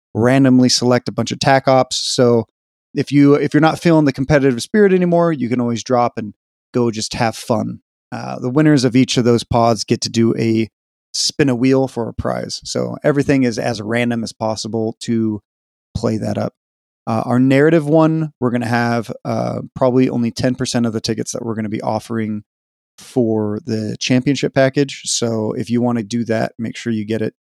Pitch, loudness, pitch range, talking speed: 120 Hz, -17 LUFS, 110-135 Hz, 200 wpm